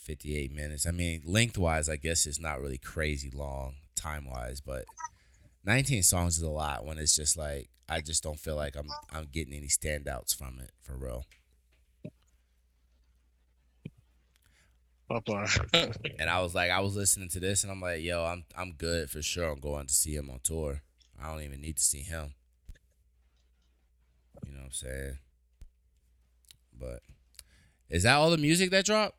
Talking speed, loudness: 175 wpm, -30 LUFS